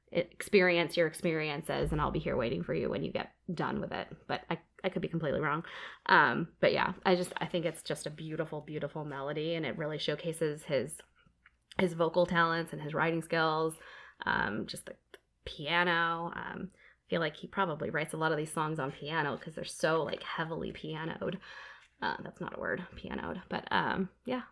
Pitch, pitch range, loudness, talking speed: 165 Hz, 155-175 Hz, -33 LUFS, 200 wpm